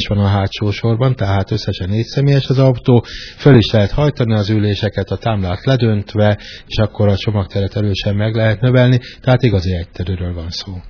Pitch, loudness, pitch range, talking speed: 105 Hz, -15 LUFS, 100-120 Hz, 180 wpm